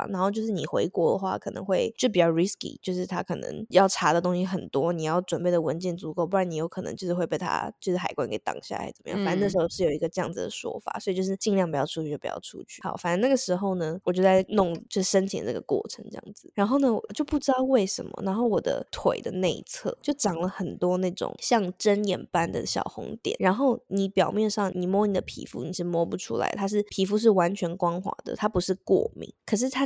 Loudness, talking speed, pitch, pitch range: -27 LUFS, 370 characters per minute, 190 Hz, 175-210 Hz